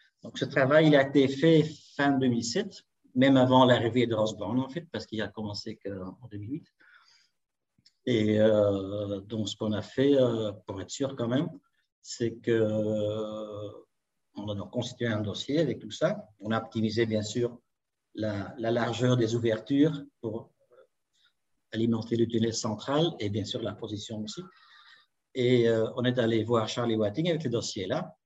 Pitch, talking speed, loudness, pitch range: 115 Hz, 165 wpm, -28 LUFS, 110-130 Hz